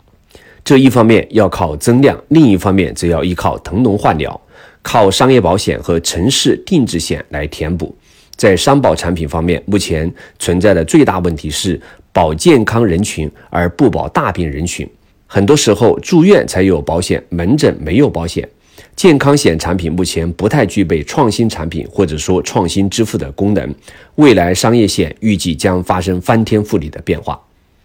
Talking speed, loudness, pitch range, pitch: 260 characters per minute, -12 LUFS, 85-110 Hz, 90 Hz